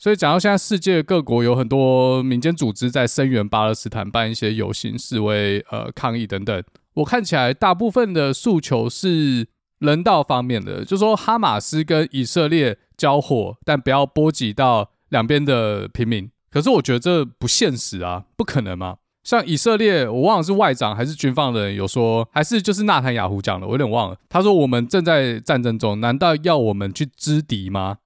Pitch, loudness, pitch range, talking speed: 130 Hz, -19 LUFS, 115-155 Hz, 300 characters per minute